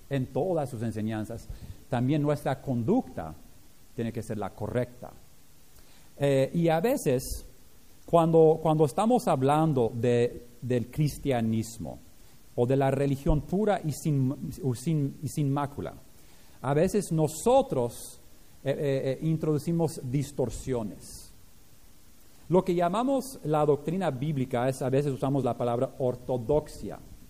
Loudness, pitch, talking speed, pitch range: -28 LUFS, 135 Hz, 120 wpm, 120-155 Hz